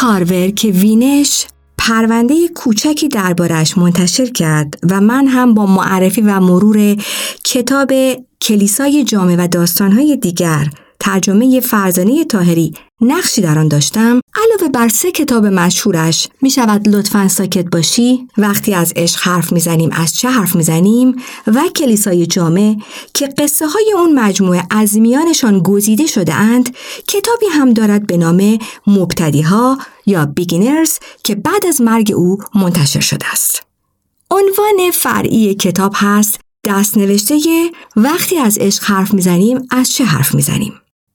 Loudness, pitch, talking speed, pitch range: -11 LUFS, 215 Hz, 140 wpm, 185-260 Hz